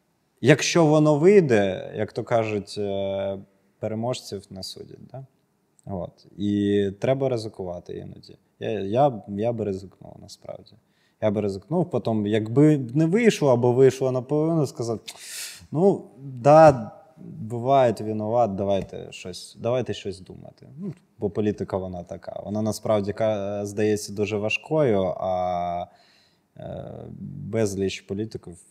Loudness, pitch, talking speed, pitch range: -23 LUFS, 110 Hz, 115 wpm, 100-140 Hz